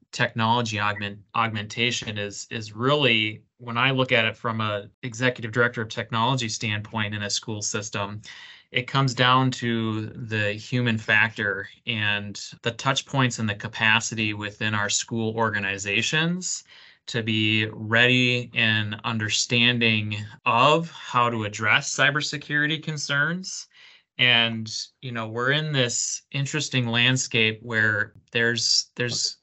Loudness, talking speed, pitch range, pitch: -23 LUFS, 125 wpm, 110-125 Hz, 115 Hz